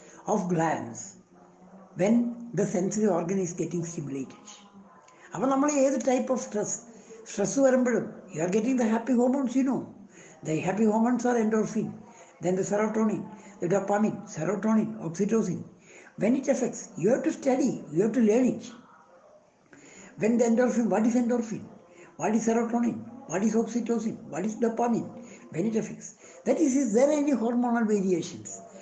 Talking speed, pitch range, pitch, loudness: 150 wpm, 195-240 Hz, 220 Hz, -27 LUFS